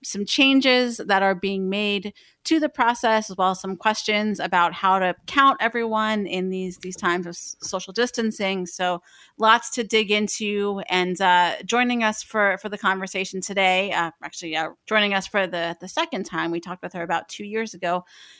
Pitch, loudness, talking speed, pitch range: 195 Hz, -22 LUFS, 190 wpm, 180-220 Hz